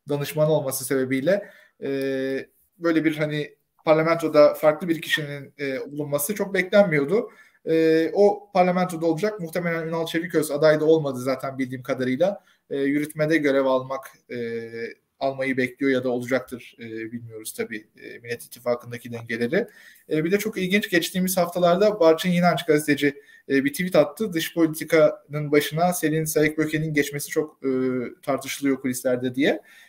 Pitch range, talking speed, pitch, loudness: 135-165 Hz, 140 wpm, 150 Hz, -23 LUFS